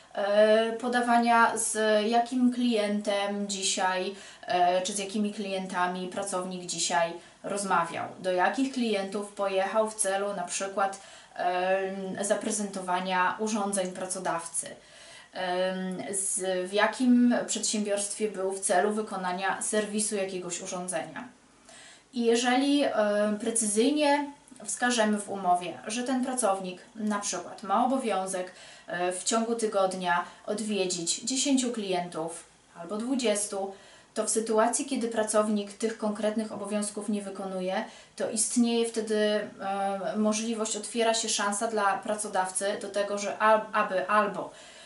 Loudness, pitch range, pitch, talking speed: -28 LUFS, 190-220 Hz, 205 Hz, 105 wpm